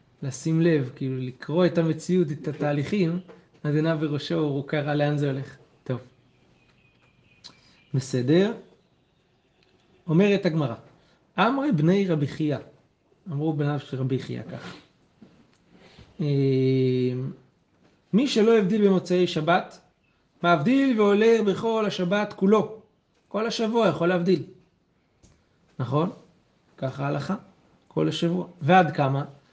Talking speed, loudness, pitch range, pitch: 100 wpm, -24 LUFS, 140-190 Hz, 165 Hz